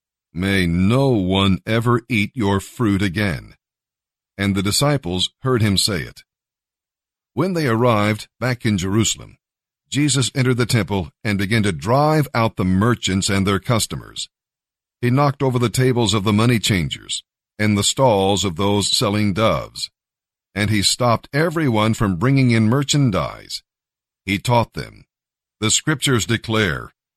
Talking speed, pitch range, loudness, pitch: 145 wpm, 100-125 Hz, -18 LUFS, 110 Hz